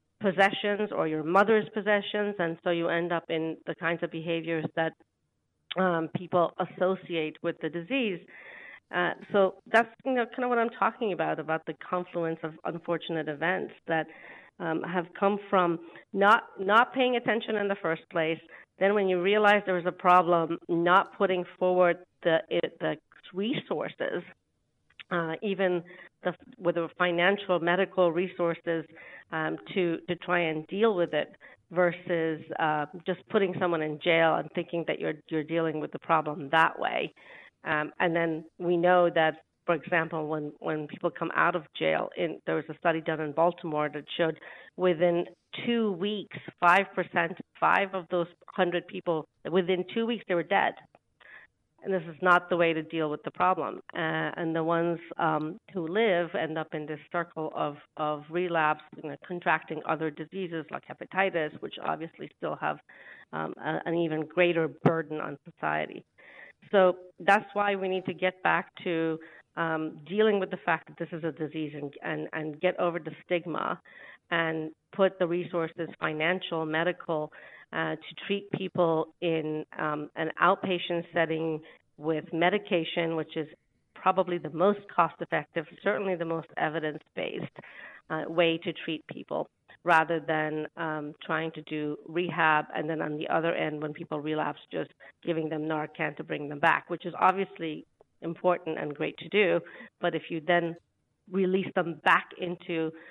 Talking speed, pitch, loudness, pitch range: 165 wpm, 170 Hz, -29 LUFS, 160-180 Hz